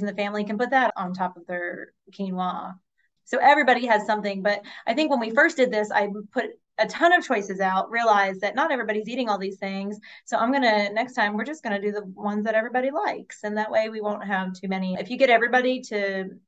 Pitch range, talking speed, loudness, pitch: 195-245 Hz, 235 wpm, -24 LUFS, 210 Hz